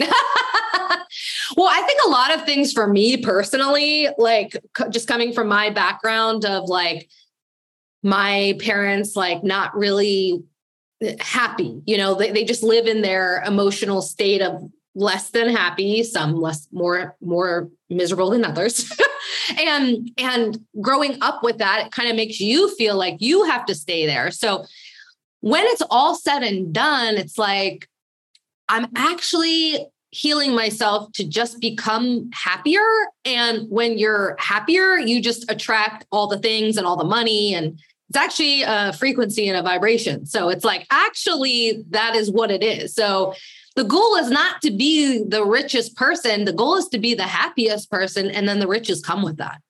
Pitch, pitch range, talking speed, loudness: 220 Hz, 195-265 Hz, 165 wpm, -19 LUFS